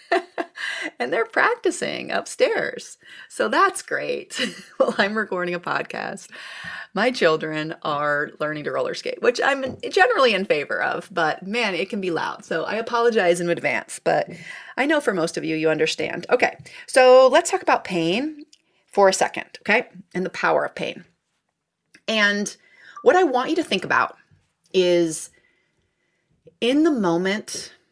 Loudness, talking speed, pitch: -21 LUFS, 155 wpm, 220 Hz